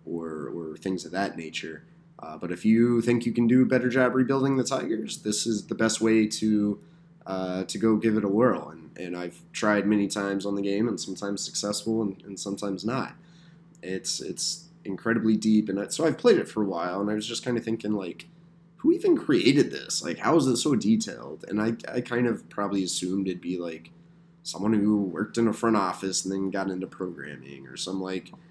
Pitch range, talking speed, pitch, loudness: 95-125 Hz, 220 wpm, 105 Hz, -26 LUFS